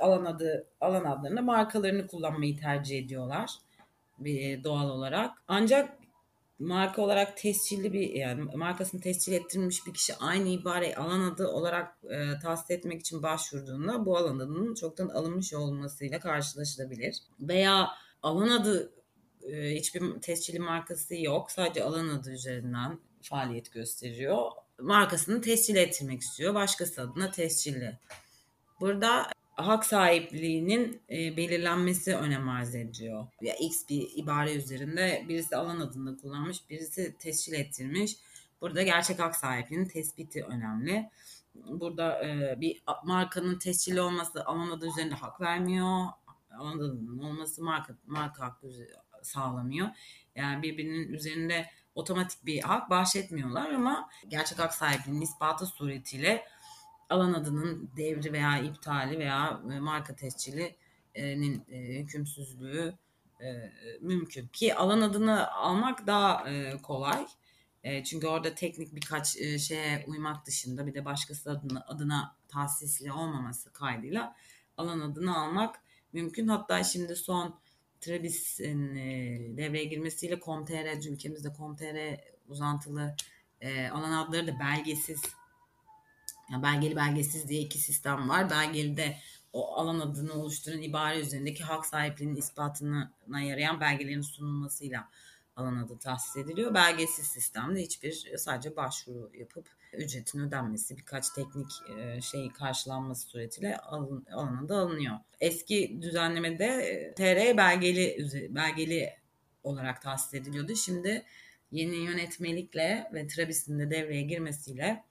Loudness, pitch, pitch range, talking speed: -32 LUFS, 155 Hz, 140-175 Hz, 120 wpm